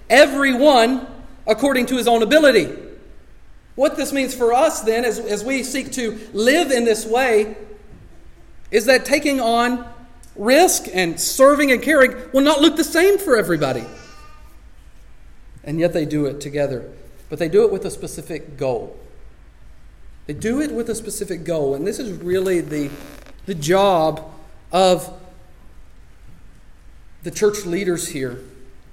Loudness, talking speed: -18 LUFS, 145 wpm